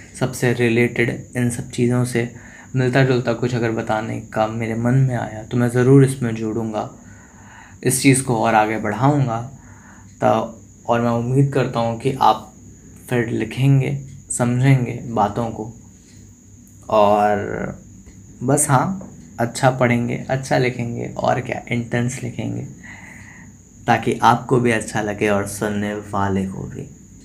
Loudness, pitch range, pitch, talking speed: -19 LUFS, 110-125 Hz, 115 Hz, 135 wpm